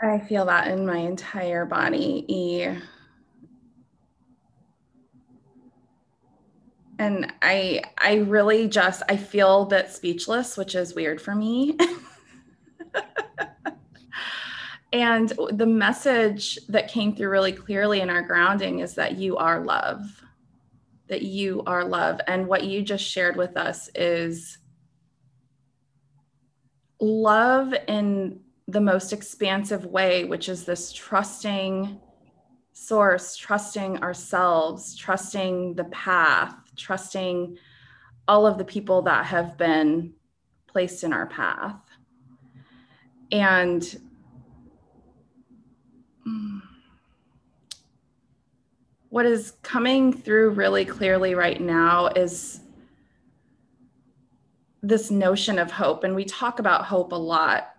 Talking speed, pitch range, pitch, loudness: 100 wpm, 165-210 Hz, 185 Hz, -23 LUFS